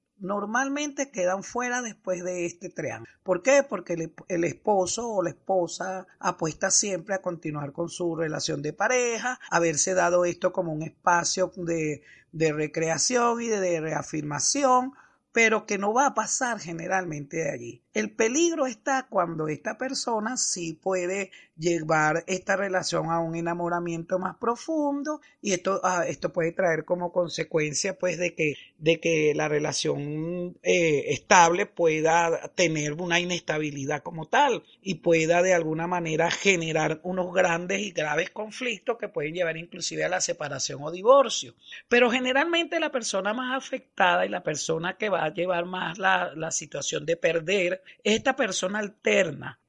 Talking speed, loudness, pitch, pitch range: 155 wpm, -26 LUFS, 180 Hz, 165-215 Hz